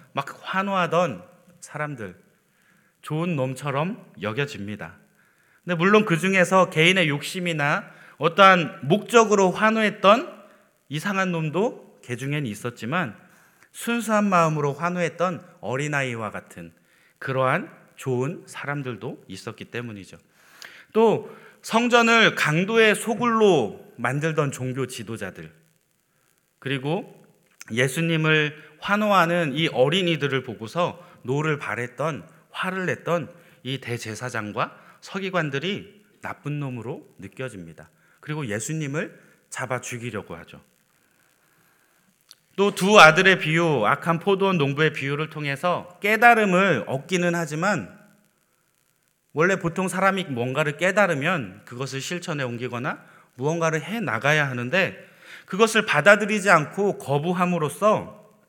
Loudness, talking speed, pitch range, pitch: -22 LUFS, 265 characters per minute, 135-190 Hz, 165 Hz